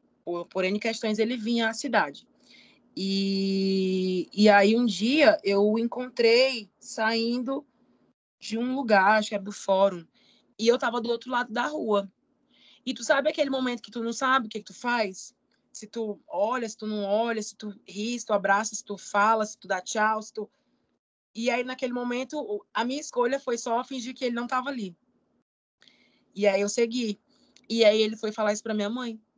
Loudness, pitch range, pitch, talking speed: -26 LUFS, 205-250 Hz, 225 Hz, 195 wpm